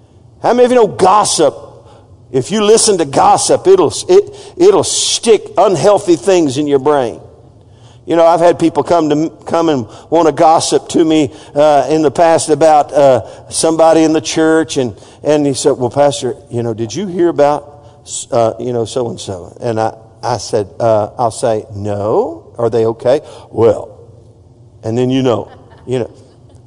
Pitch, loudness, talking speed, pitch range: 145 Hz, -12 LUFS, 190 wpm, 115-165 Hz